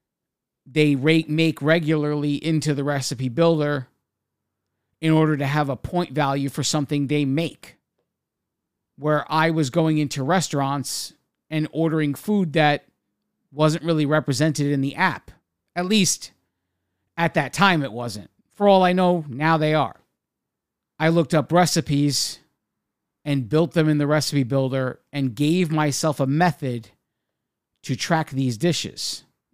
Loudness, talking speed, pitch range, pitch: -21 LUFS, 140 wpm, 140-160 Hz, 150 Hz